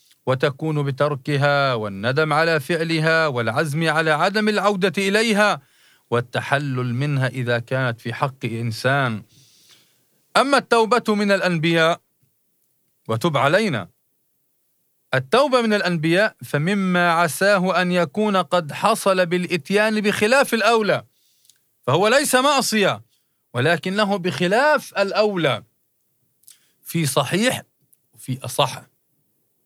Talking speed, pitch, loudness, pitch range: 90 wpm, 165 Hz, -20 LUFS, 140-205 Hz